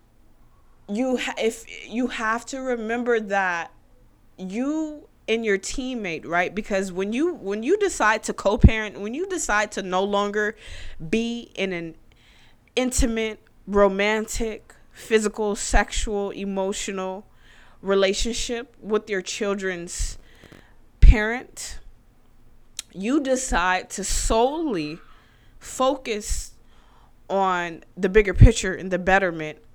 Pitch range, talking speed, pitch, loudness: 185-230 Hz, 105 wpm, 205 Hz, -24 LUFS